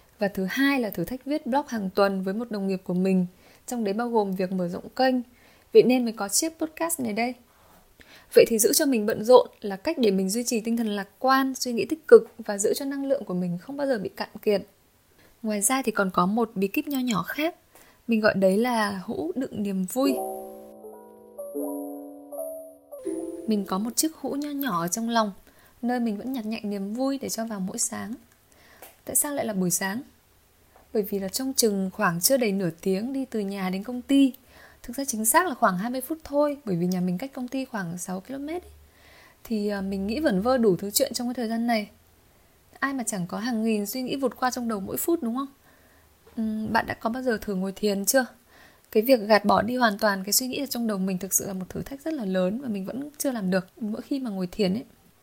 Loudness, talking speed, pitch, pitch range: -25 LUFS, 240 wpm, 225 Hz, 195-260 Hz